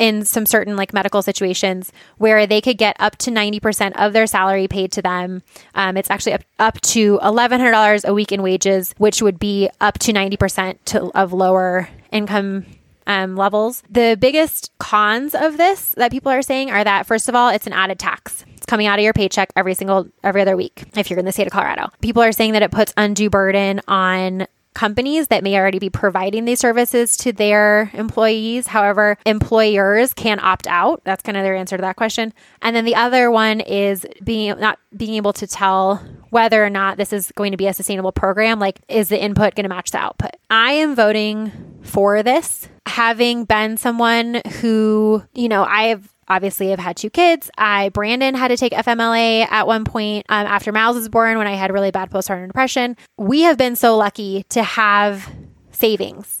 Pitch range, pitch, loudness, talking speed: 195-225 Hz, 210 Hz, -16 LUFS, 205 wpm